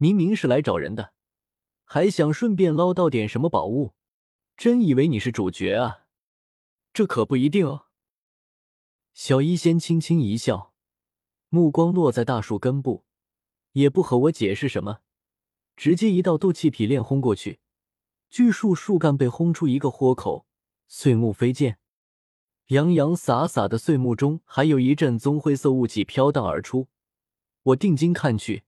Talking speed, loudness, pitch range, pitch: 225 characters per minute, -22 LUFS, 120-165 Hz, 140 Hz